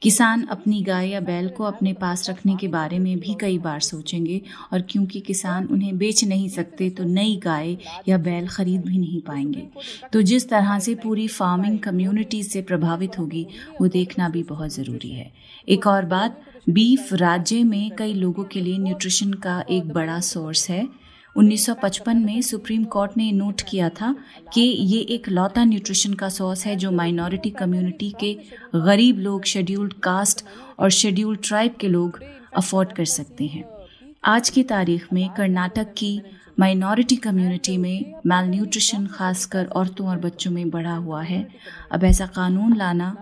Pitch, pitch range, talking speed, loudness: 190 Hz, 180-210 Hz, 165 wpm, -21 LUFS